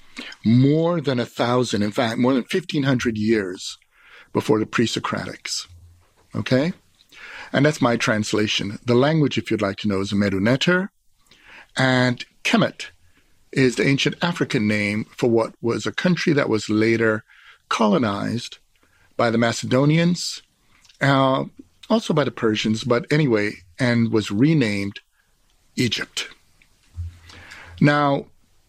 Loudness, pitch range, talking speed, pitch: -21 LUFS, 105-145 Hz, 125 wpm, 120 Hz